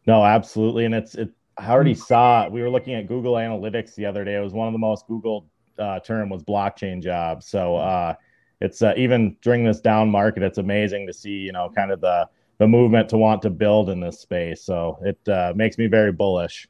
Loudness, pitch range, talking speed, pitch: -21 LUFS, 100-115 Hz, 225 wpm, 110 Hz